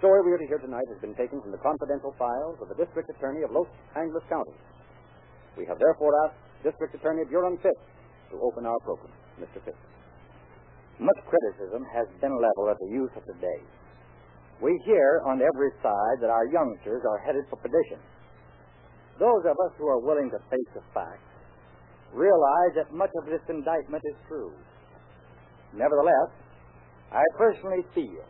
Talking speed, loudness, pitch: 170 wpm, -27 LUFS, 150 Hz